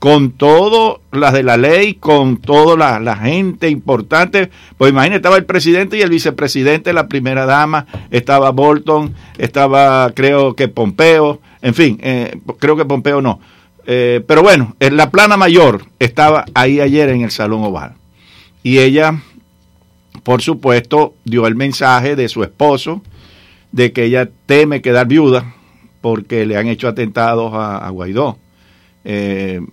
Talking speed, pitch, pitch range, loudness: 150 wpm, 135 Hz, 115-150 Hz, -11 LUFS